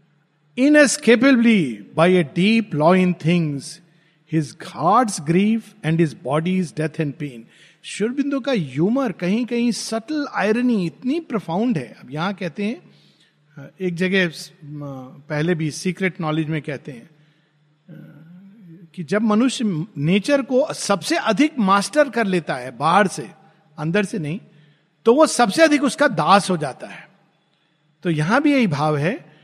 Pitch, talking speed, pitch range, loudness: 180 Hz, 135 wpm, 155-220 Hz, -19 LUFS